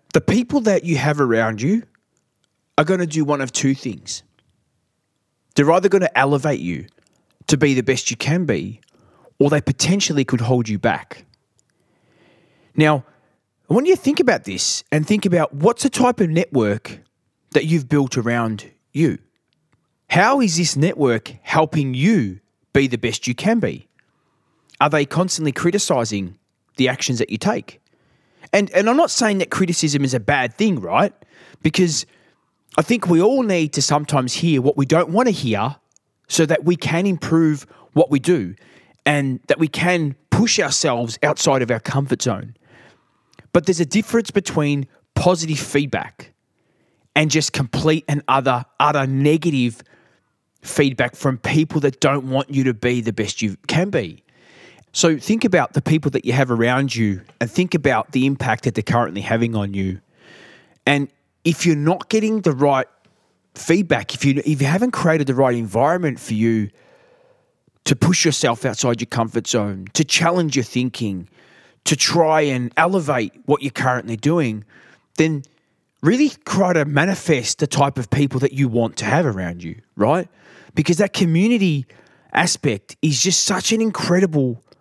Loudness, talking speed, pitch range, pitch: -18 LUFS, 165 wpm, 125-170 Hz, 145 Hz